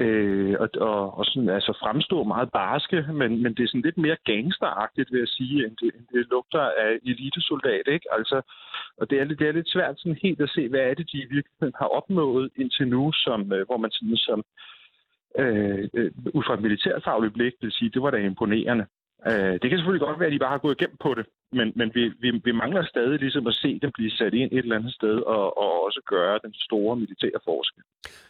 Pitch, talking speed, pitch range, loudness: 125 Hz, 225 wpm, 110-145 Hz, -25 LUFS